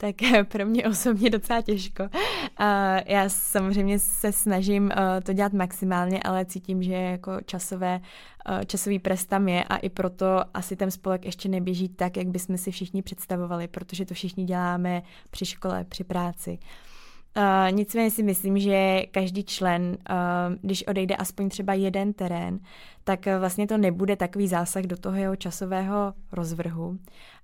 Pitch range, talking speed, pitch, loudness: 185-200 Hz, 145 wpm, 190 Hz, -26 LUFS